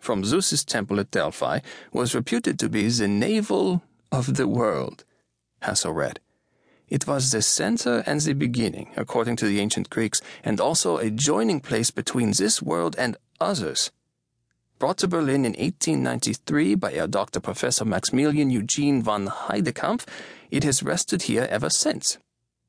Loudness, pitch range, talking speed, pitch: -24 LUFS, 105-145 Hz, 155 wpm, 120 Hz